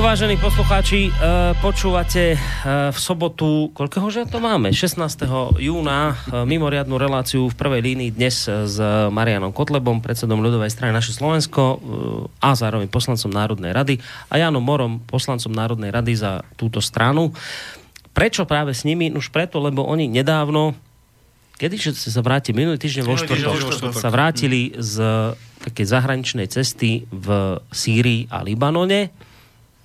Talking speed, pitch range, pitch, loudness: 130 wpm, 115-150 Hz, 130 Hz, -20 LUFS